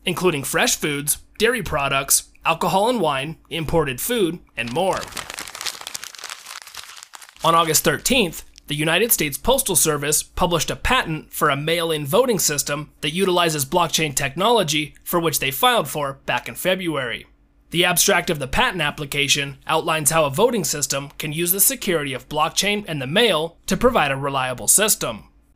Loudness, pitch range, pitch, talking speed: -19 LUFS, 145-180 Hz, 160 Hz, 155 wpm